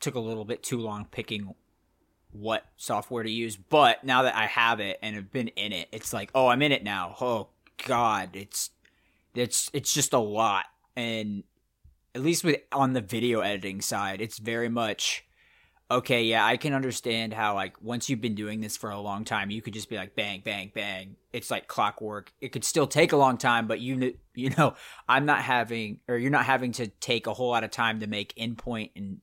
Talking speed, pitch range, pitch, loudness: 215 wpm, 105-125 Hz, 115 Hz, -27 LUFS